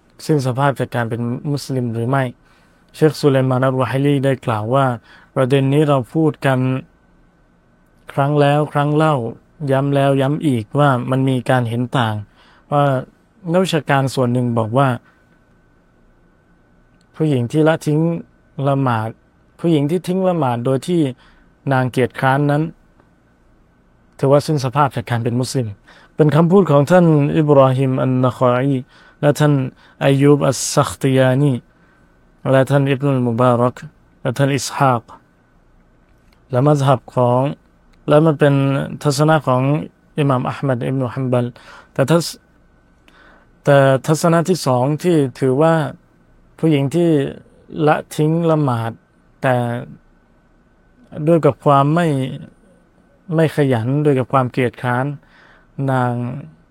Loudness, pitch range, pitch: -17 LUFS, 125-150 Hz, 135 Hz